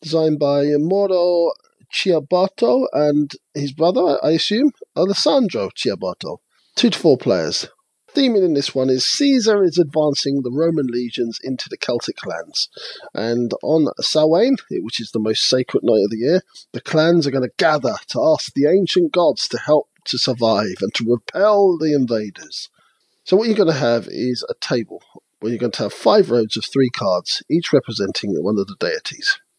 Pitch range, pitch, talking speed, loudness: 130-185 Hz, 150 Hz, 180 wpm, -18 LUFS